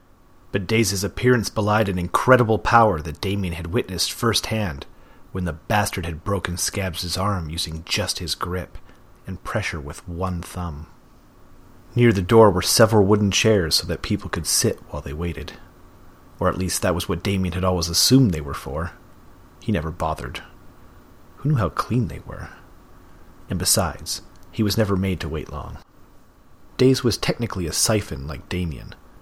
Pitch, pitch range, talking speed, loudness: 90 Hz, 85-105 Hz, 165 wpm, -21 LUFS